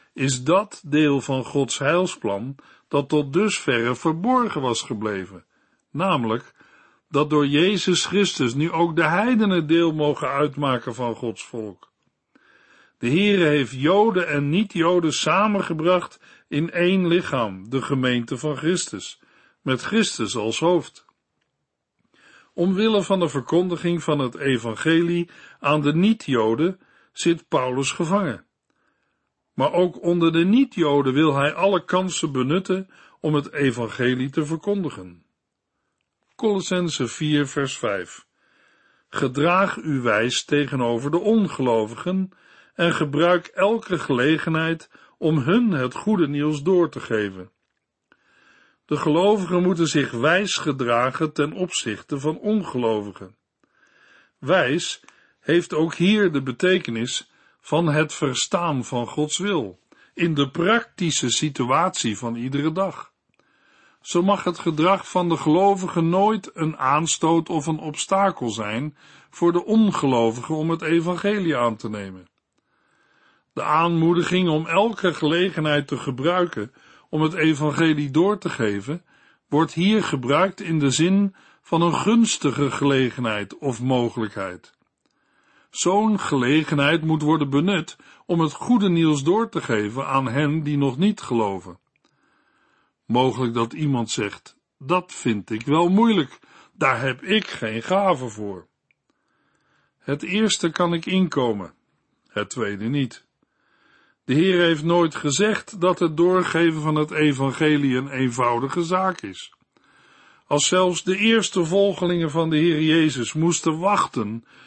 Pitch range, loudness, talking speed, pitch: 135-180 Hz, -21 LUFS, 125 wpm, 155 Hz